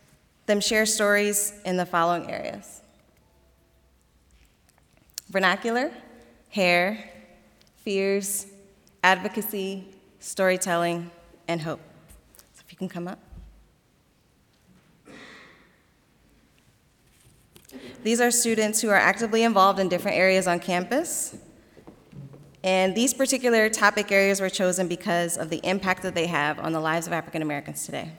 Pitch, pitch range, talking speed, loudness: 185 Hz, 170-205 Hz, 115 wpm, -24 LUFS